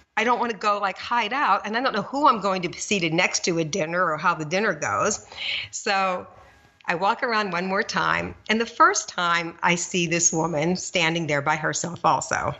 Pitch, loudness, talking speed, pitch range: 190 Hz, -23 LUFS, 225 wpm, 170-215 Hz